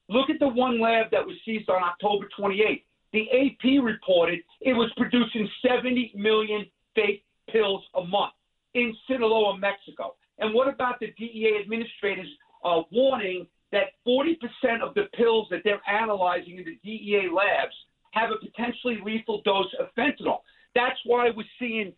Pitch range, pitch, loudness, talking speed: 200-245 Hz, 220 Hz, -26 LUFS, 160 wpm